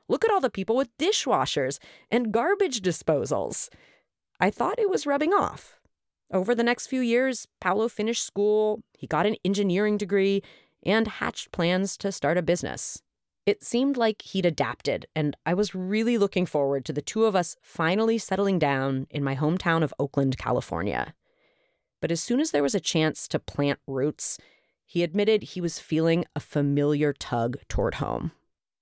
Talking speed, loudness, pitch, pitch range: 170 wpm, -26 LUFS, 185 Hz, 150-225 Hz